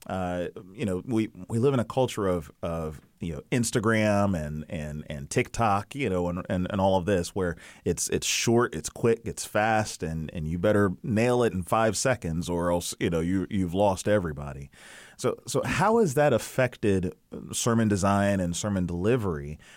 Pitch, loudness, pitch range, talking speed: 100 Hz, -27 LUFS, 85-115 Hz, 190 wpm